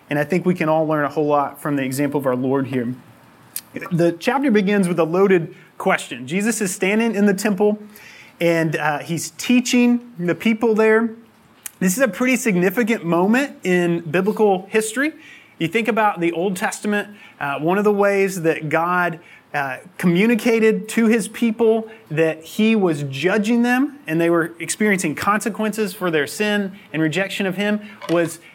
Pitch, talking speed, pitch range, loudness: 195 Hz, 170 wpm, 165-220 Hz, -19 LUFS